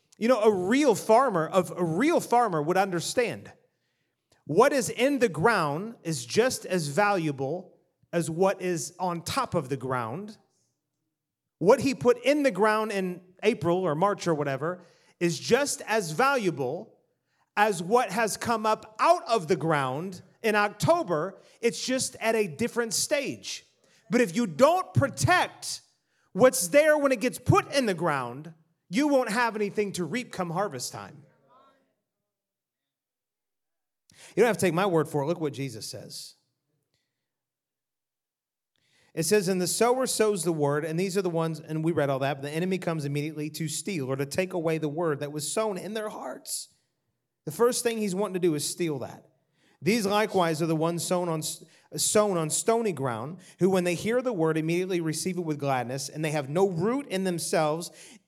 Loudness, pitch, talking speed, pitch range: -26 LUFS, 180 Hz, 180 wpm, 160-220 Hz